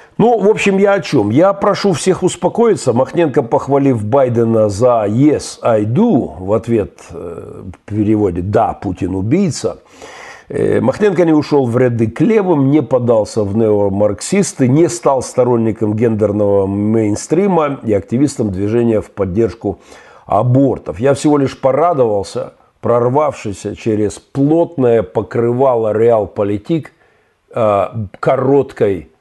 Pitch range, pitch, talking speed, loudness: 105-150 Hz, 120 Hz, 110 wpm, -14 LUFS